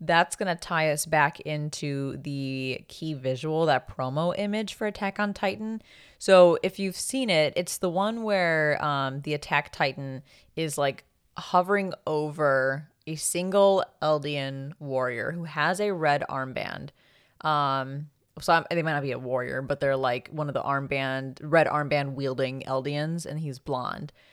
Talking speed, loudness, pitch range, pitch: 160 wpm, -27 LUFS, 135-175 Hz, 150 Hz